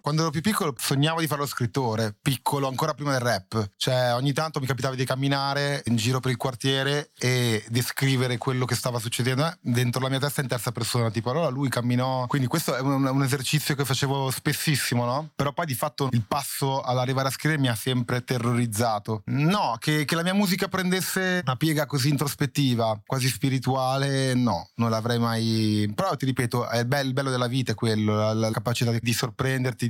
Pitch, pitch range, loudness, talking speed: 130 Hz, 120-145 Hz, -25 LUFS, 200 wpm